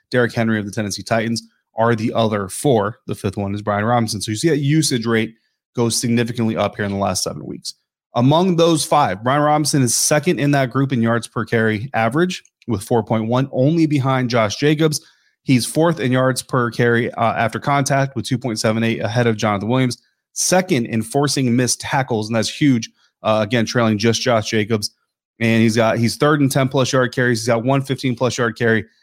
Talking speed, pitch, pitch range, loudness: 215 wpm, 120 Hz, 110-135 Hz, -18 LUFS